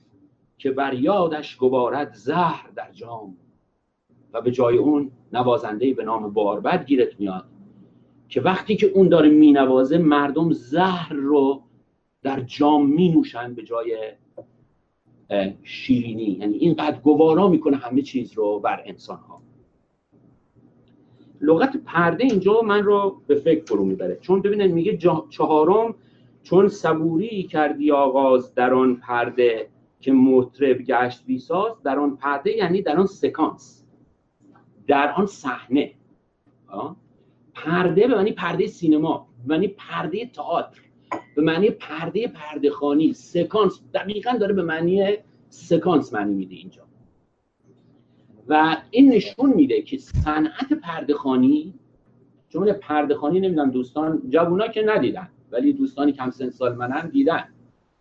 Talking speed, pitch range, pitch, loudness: 125 wpm, 130-195 Hz, 155 Hz, -20 LUFS